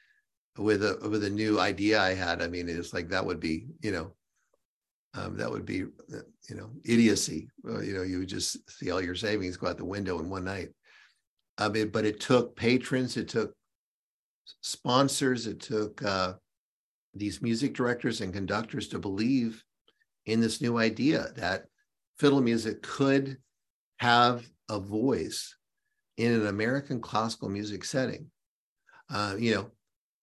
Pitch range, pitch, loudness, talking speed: 100-125 Hz, 110 Hz, -30 LUFS, 160 wpm